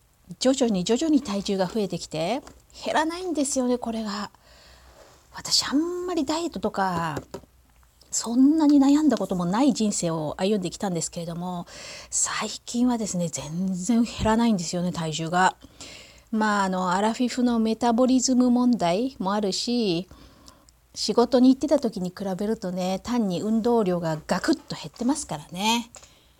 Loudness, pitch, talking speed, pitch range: -24 LUFS, 215 Hz, 330 characters per minute, 180-250 Hz